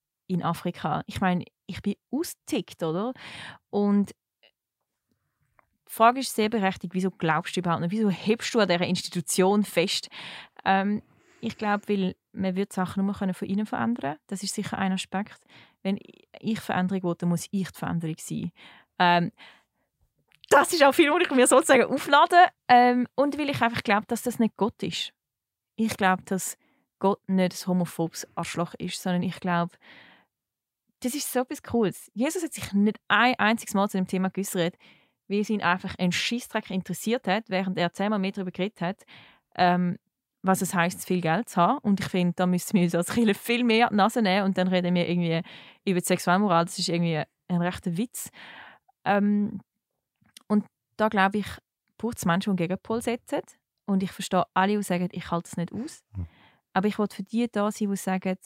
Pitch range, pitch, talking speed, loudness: 180-220 Hz, 195 Hz, 190 wpm, -26 LUFS